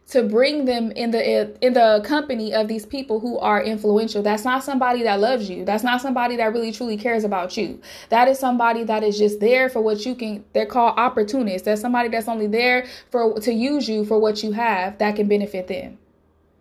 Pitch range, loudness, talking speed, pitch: 210-245 Hz, -20 LUFS, 215 wpm, 225 Hz